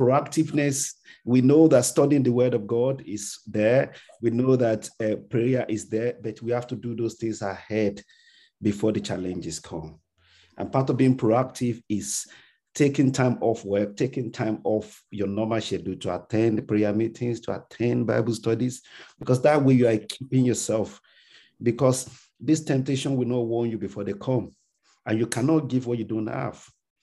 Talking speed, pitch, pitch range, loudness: 175 wpm, 115 Hz, 105-130 Hz, -25 LUFS